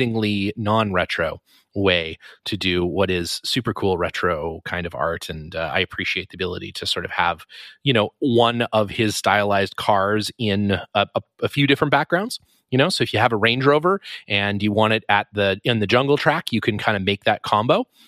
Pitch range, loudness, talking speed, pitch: 100-120 Hz, -21 LUFS, 205 wpm, 105 Hz